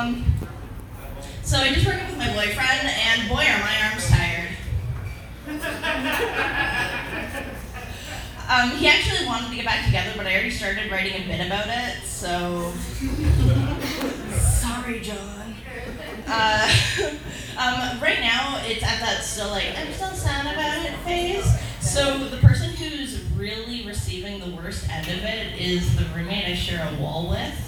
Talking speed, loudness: 150 wpm, -23 LUFS